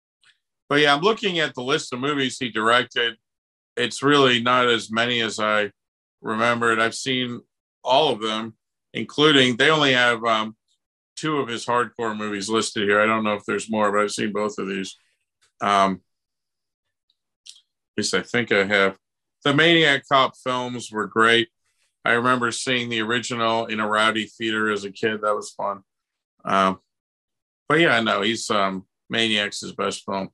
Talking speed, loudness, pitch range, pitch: 170 wpm, -21 LUFS, 105-125 Hz, 115 Hz